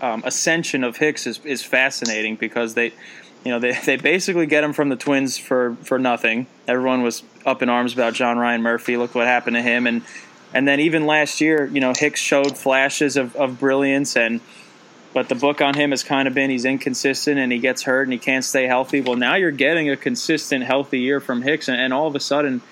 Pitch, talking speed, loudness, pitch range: 130 Hz, 230 wpm, -19 LUFS, 125-140 Hz